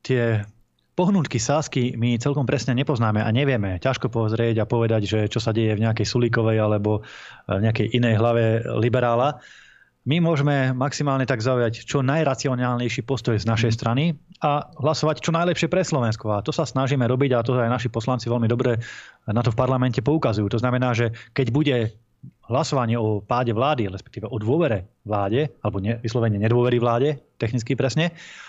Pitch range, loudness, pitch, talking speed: 115-135 Hz, -22 LUFS, 120 Hz, 170 wpm